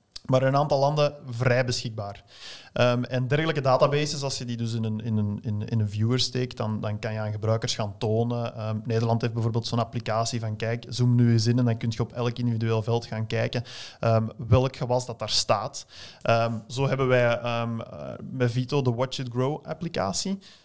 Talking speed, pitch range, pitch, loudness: 205 wpm, 115-125 Hz, 120 Hz, -26 LUFS